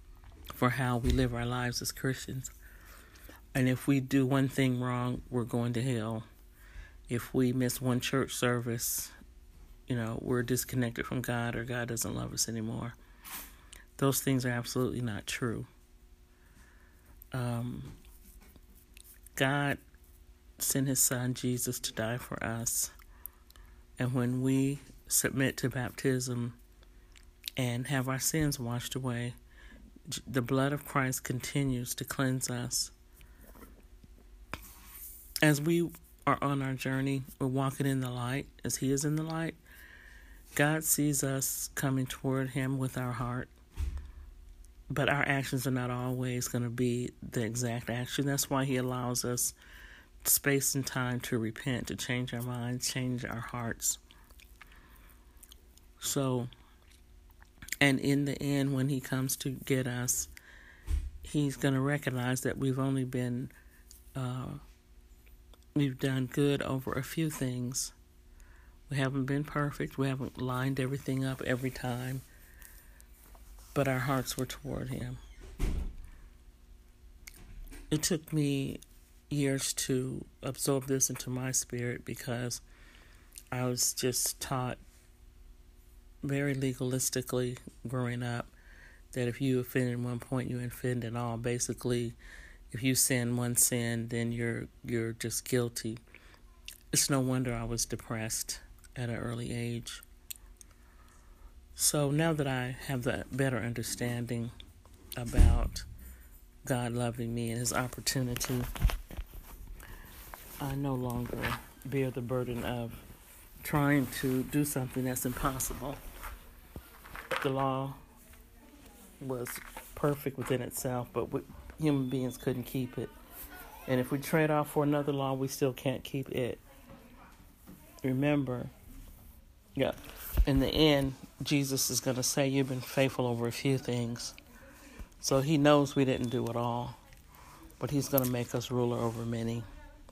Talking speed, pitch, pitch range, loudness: 135 wpm, 125 Hz, 90-135 Hz, -32 LUFS